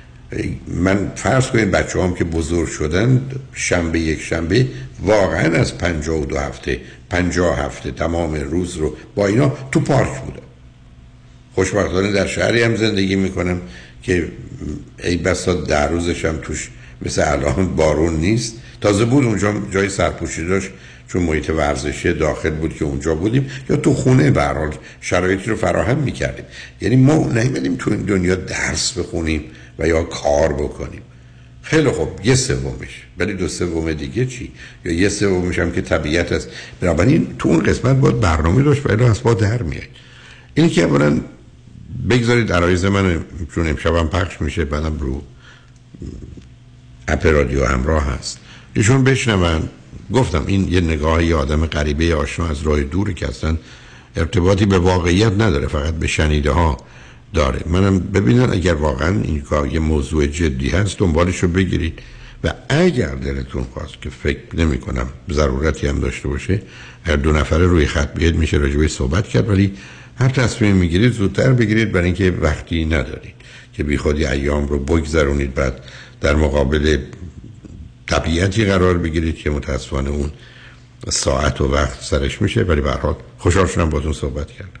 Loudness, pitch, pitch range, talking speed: -18 LUFS, 85 Hz, 75-100 Hz, 155 wpm